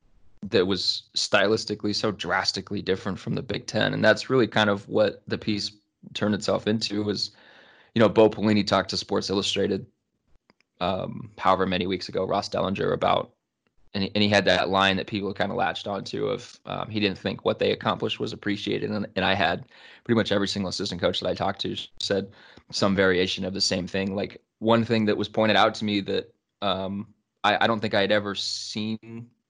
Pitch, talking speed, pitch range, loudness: 100 Hz, 205 wpm, 95-110 Hz, -25 LUFS